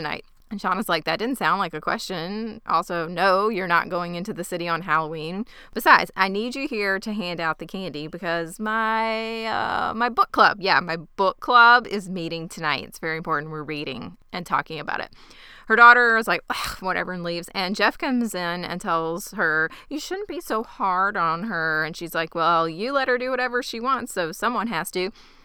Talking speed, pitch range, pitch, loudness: 210 wpm, 165-225 Hz, 185 Hz, -22 LUFS